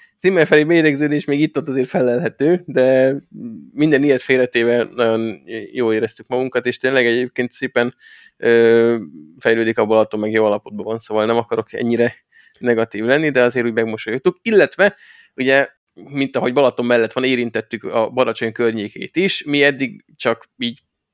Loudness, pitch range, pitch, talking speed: -17 LUFS, 115-140 Hz, 125 Hz, 150 wpm